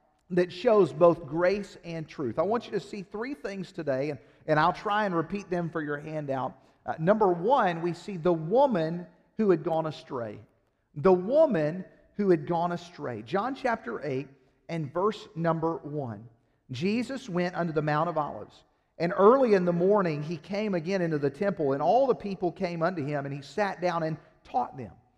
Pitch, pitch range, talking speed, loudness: 170 Hz, 155-195 Hz, 190 wpm, -28 LUFS